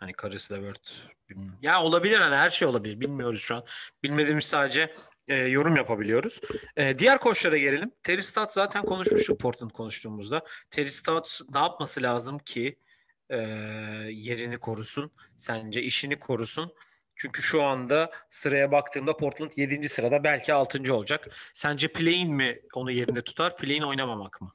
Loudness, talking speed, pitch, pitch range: -27 LUFS, 145 wpm, 140 Hz, 120-160 Hz